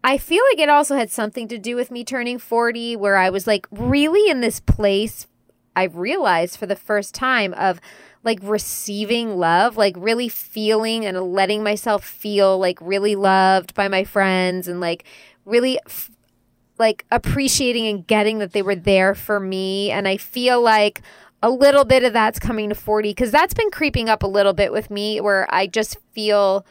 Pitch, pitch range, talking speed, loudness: 210 Hz, 195-235 Hz, 190 wpm, -19 LUFS